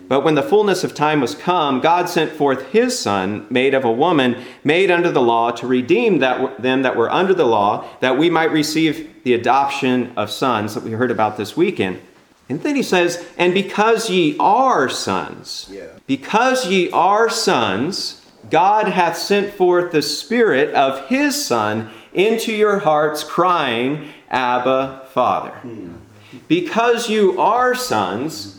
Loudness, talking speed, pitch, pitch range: -17 LUFS, 160 wpm, 155 Hz, 125-205 Hz